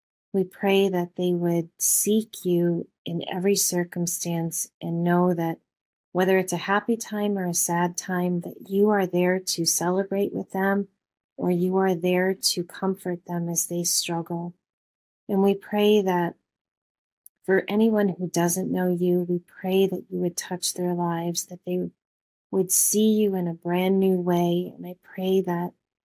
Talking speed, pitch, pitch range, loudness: 165 wpm, 180 Hz, 175-195 Hz, -24 LUFS